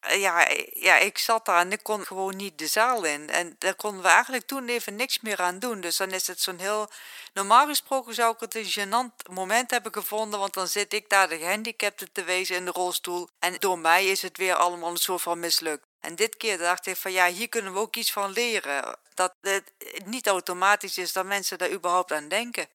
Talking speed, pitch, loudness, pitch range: 230 wpm, 195 Hz, -25 LUFS, 180-225 Hz